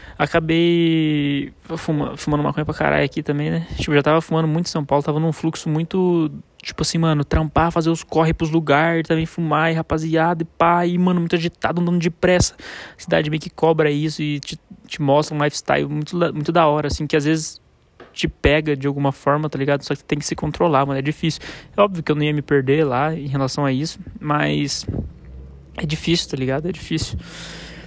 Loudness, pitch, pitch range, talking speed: -20 LUFS, 155 Hz, 145-165 Hz, 210 wpm